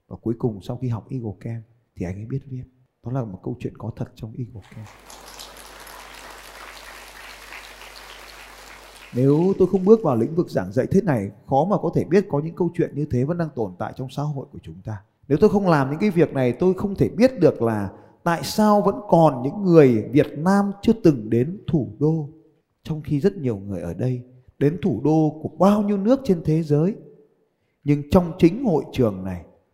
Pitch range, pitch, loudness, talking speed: 115-170 Hz, 140 Hz, -21 LUFS, 210 wpm